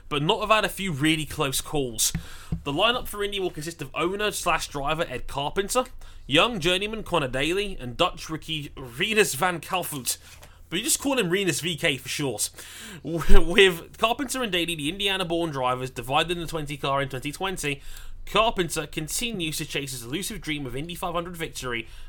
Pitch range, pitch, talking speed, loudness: 135-185 Hz, 160 Hz, 175 wpm, -25 LUFS